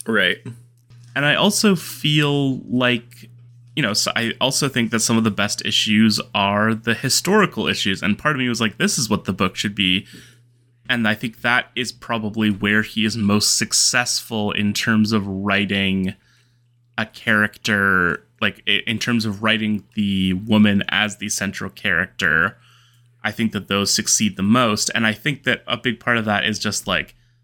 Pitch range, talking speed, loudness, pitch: 105-120 Hz, 180 wpm, -19 LUFS, 110 Hz